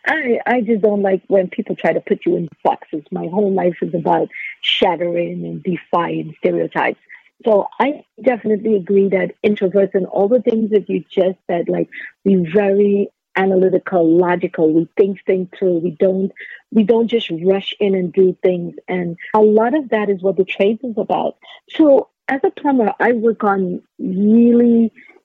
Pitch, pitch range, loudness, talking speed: 195 Hz, 180-220 Hz, -17 LUFS, 175 wpm